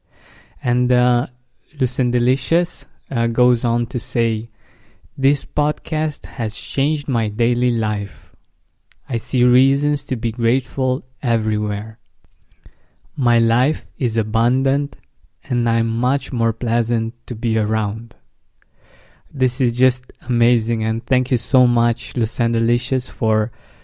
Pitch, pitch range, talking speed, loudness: 120 Hz, 115-130 Hz, 115 wpm, -19 LUFS